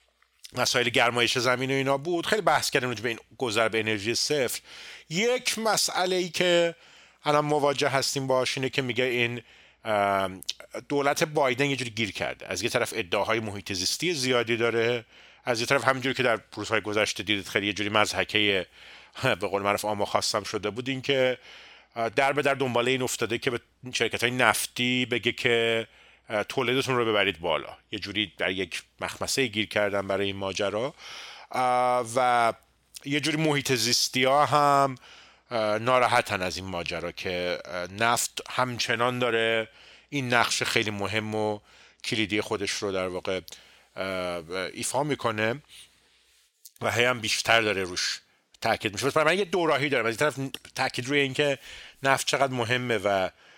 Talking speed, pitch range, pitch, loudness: 155 wpm, 105-135 Hz, 120 Hz, -26 LUFS